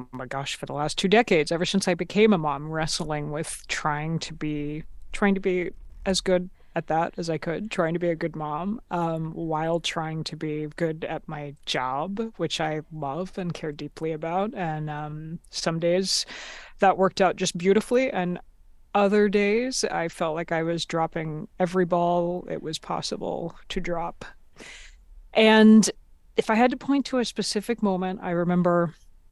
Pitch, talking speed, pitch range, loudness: 170 Hz, 180 wpm, 155-190 Hz, -25 LUFS